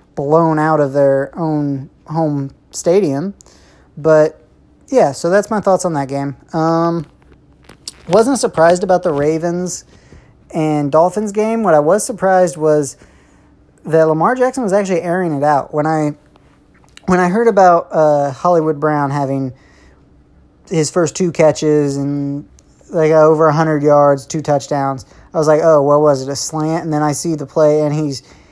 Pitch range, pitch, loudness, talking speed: 145-170 Hz, 155 Hz, -14 LUFS, 160 wpm